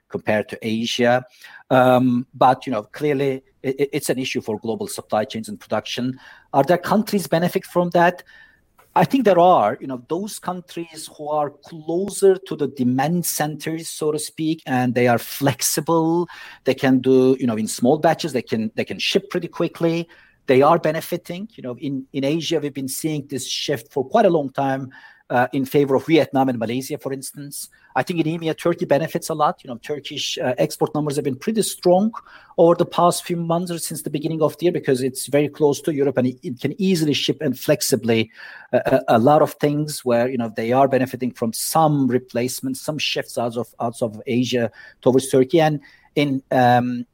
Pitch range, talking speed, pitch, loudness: 130-165 Hz, 200 wpm, 145 Hz, -20 LUFS